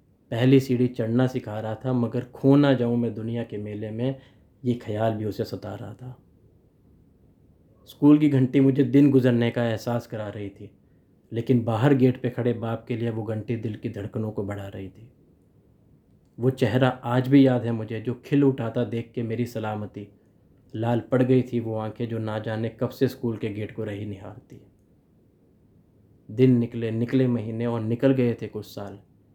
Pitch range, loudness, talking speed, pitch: 110-125 Hz, -24 LUFS, 185 wpm, 115 Hz